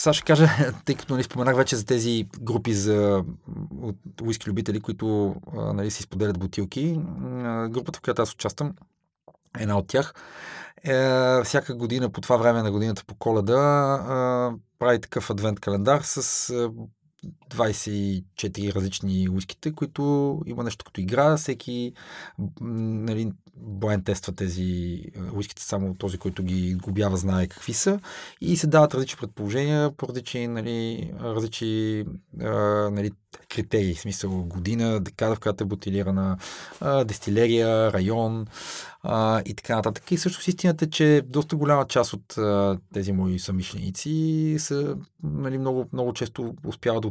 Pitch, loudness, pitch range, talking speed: 115 Hz, -25 LUFS, 100-135 Hz, 145 wpm